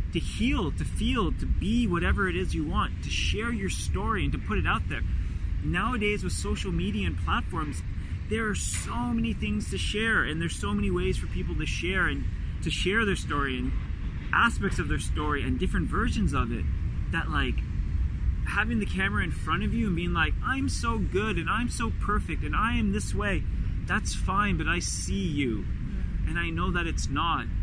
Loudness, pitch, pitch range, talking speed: -28 LUFS, 85 Hz, 75-95 Hz, 205 wpm